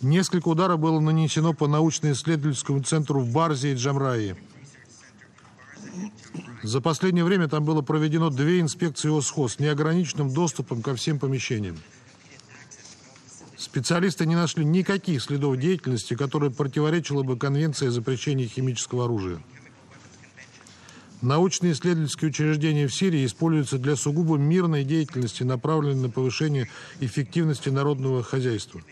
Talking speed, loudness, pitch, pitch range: 115 wpm, -24 LUFS, 145 Hz, 130-160 Hz